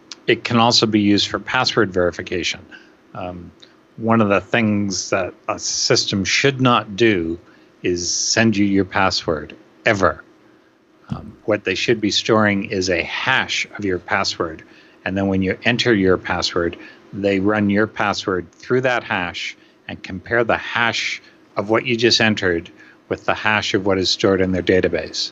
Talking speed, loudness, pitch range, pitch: 165 wpm, -18 LUFS, 95-115 Hz, 105 Hz